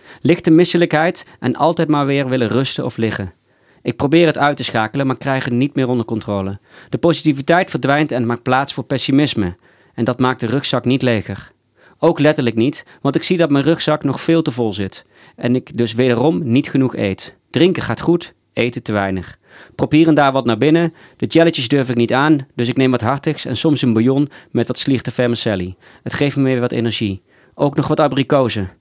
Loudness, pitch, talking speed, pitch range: -16 LUFS, 135 Hz, 205 wpm, 120-150 Hz